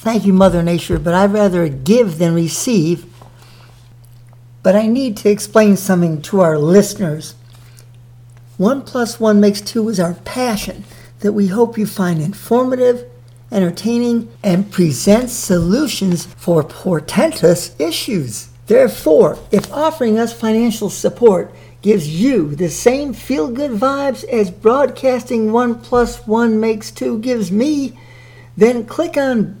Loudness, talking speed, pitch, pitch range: -15 LUFS, 130 wpm, 200 Hz, 165-235 Hz